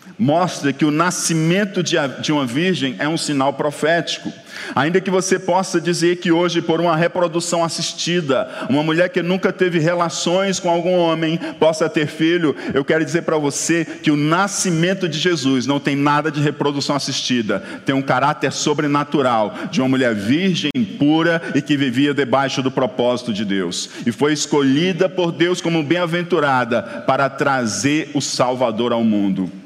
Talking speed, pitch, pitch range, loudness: 160 wpm, 160 Hz, 140-175 Hz, -18 LUFS